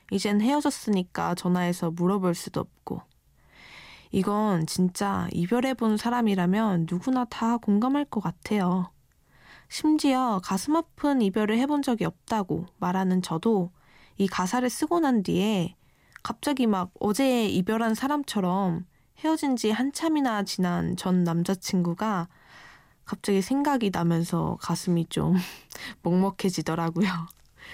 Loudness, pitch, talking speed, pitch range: -26 LUFS, 200 Hz, 270 characters per minute, 180-240 Hz